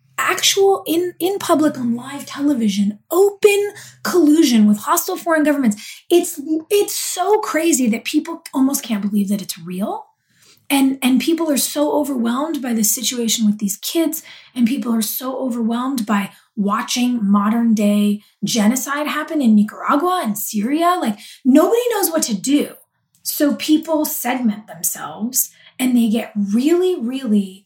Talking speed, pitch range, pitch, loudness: 145 wpm, 220-320 Hz, 265 Hz, -18 LUFS